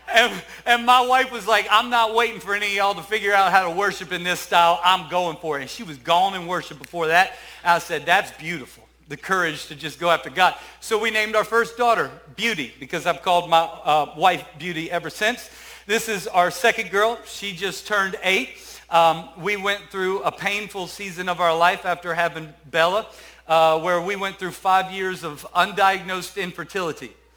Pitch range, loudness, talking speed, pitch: 170-205 Hz, -21 LUFS, 205 wpm, 185 Hz